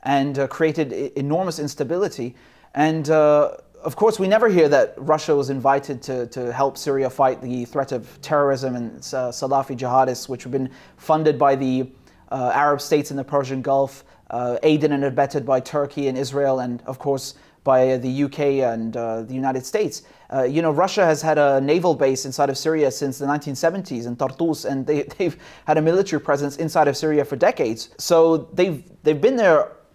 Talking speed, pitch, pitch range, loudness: 190 wpm, 140 Hz, 130-155 Hz, -21 LUFS